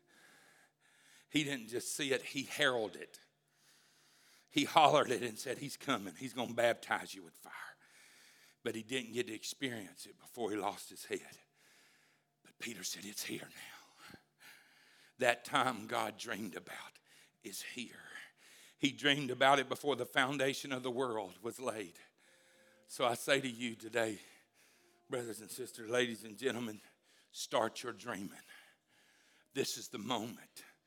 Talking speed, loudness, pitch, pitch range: 150 wpm, -37 LUFS, 125 Hz, 115-135 Hz